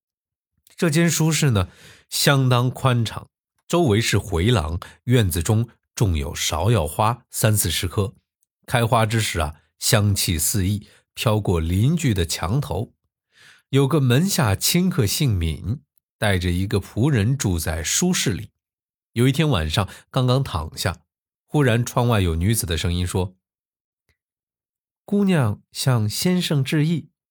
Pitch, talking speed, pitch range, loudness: 110 Hz, 195 characters per minute, 95-130 Hz, -21 LUFS